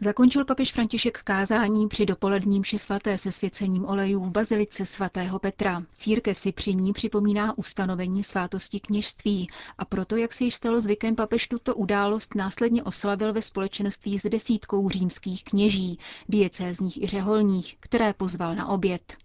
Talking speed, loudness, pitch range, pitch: 145 wpm, -26 LUFS, 195-215 Hz, 200 Hz